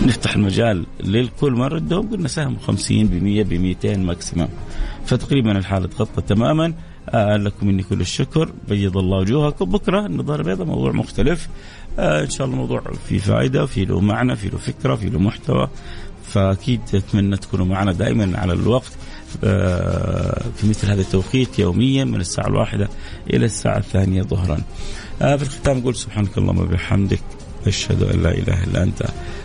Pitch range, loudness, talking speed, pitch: 95-120 Hz, -20 LUFS, 160 wpm, 105 Hz